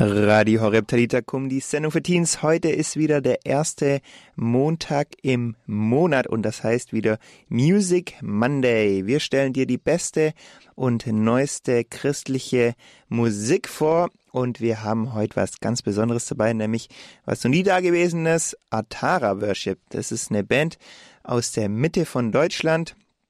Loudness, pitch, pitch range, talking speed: -22 LUFS, 125 Hz, 115-155 Hz, 150 wpm